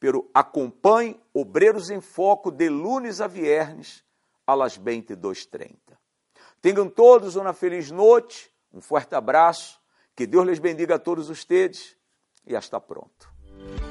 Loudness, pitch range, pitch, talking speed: -21 LUFS, 160-265 Hz, 190 Hz, 130 wpm